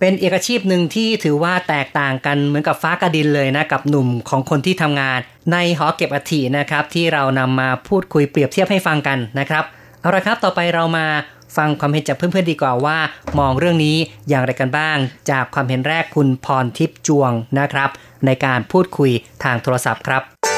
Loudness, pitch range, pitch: -17 LUFS, 135-165 Hz, 145 Hz